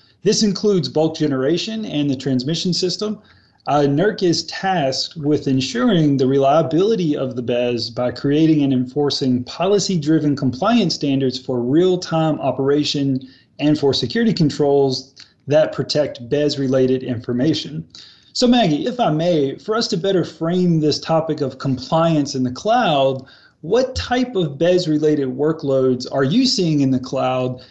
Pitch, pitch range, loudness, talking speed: 145 Hz, 130-170 Hz, -18 LUFS, 150 wpm